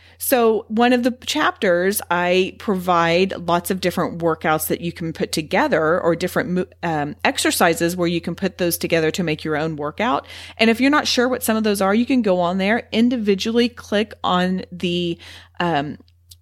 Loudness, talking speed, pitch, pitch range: -19 LUFS, 185 wpm, 180 Hz, 170-225 Hz